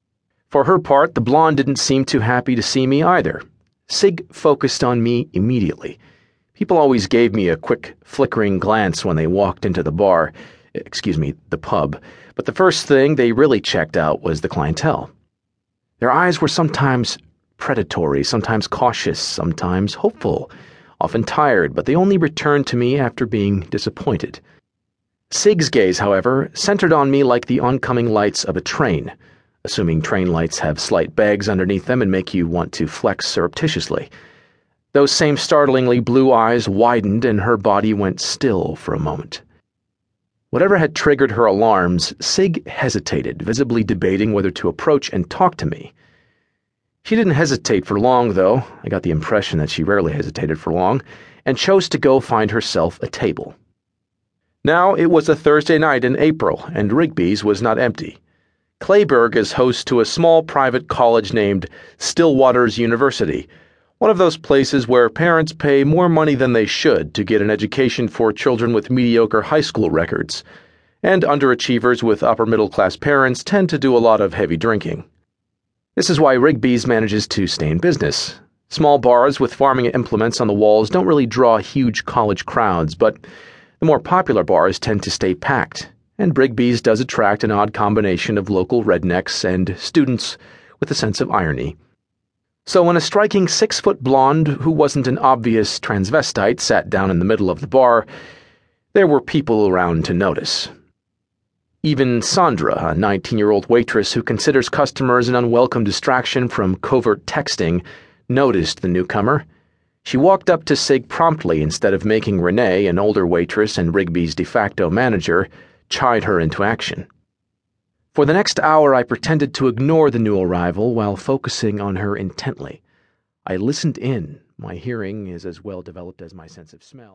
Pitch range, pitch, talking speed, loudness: 100-140 Hz, 120 Hz, 170 wpm, -16 LUFS